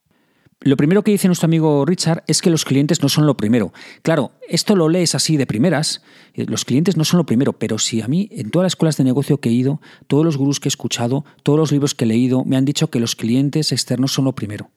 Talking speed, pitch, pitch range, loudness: 260 wpm, 145 Hz, 130-165 Hz, -17 LUFS